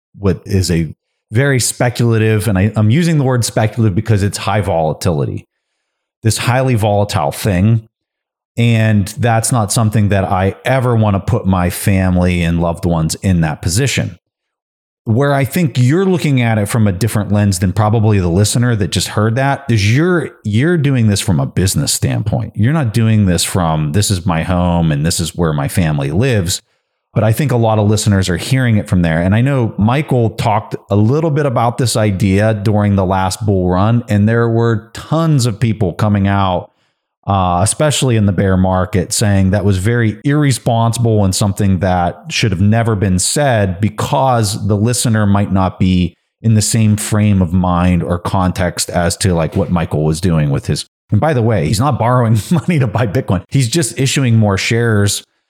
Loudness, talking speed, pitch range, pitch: -14 LUFS, 190 wpm, 95-120 Hz, 110 Hz